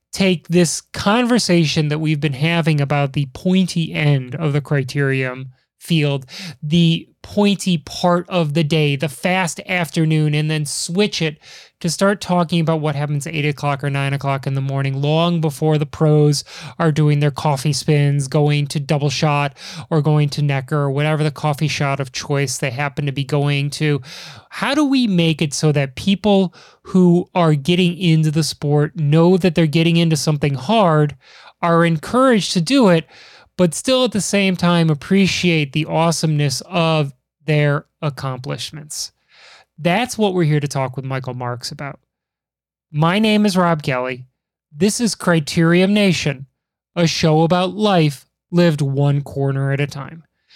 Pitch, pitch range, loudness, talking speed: 155 Hz, 145-175 Hz, -17 LUFS, 165 wpm